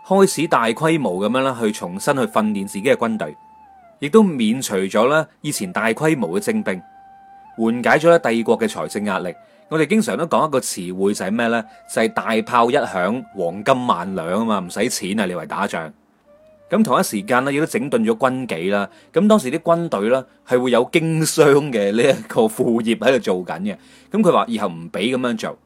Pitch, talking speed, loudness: 155 Hz, 290 characters per minute, -19 LUFS